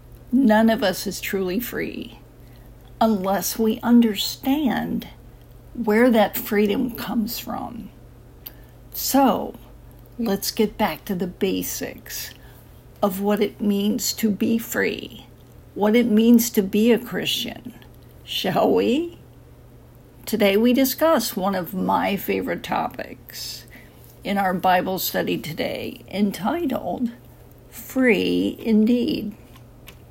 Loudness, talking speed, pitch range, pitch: -22 LUFS, 105 wpm, 195-235 Hz, 215 Hz